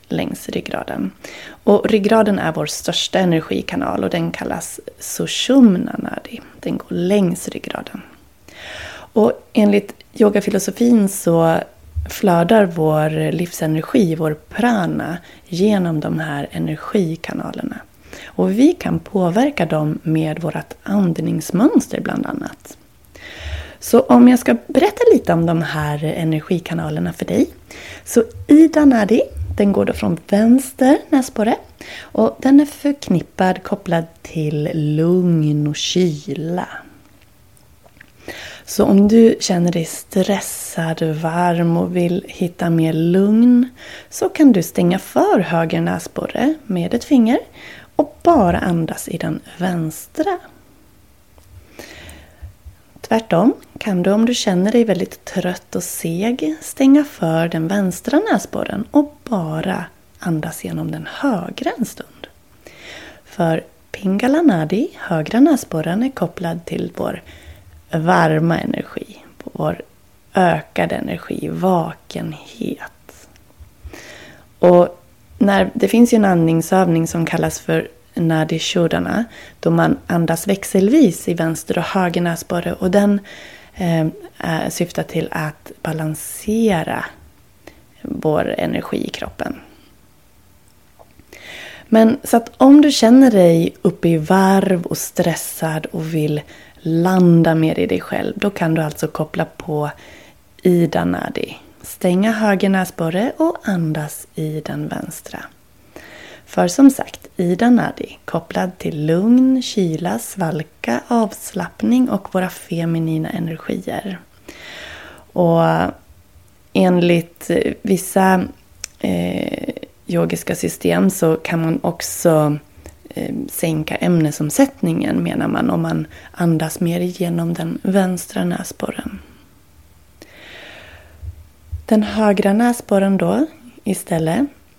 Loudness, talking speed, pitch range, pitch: -17 LUFS, 110 wpm, 160-220 Hz, 175 Hz